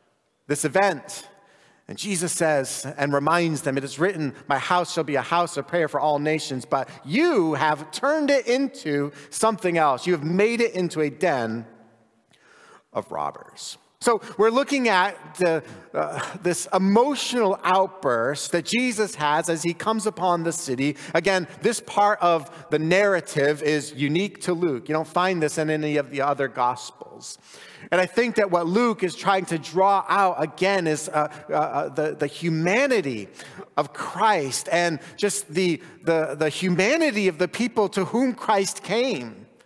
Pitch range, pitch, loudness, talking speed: 150-200 Hz, 175 Hz, -23 LUFS, 165 wpm